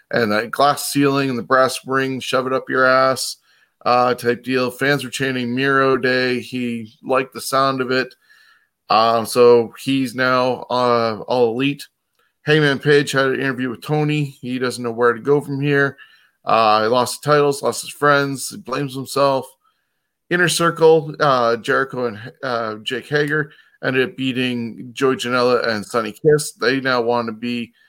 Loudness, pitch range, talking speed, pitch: -18 LUFS, 120-140 Hz, 175 wpm, 130 Hz